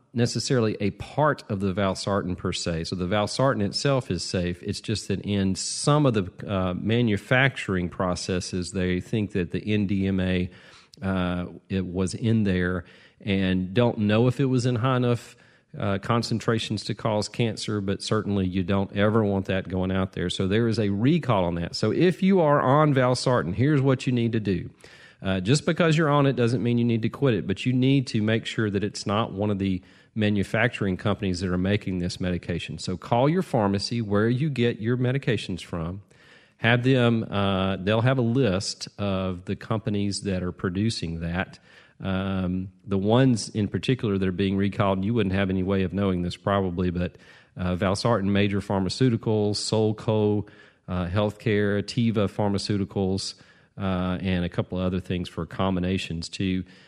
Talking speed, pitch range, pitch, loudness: 180 wpm, 95-115 Hz, 100 Hz, -25 LUFS